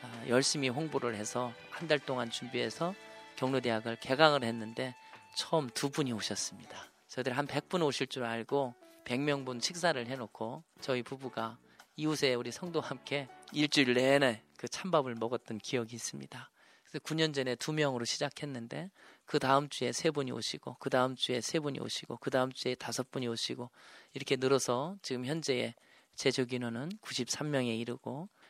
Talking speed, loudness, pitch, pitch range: 335 characters per minute, -34 LUFS, 130 Hz, 120-145 Hz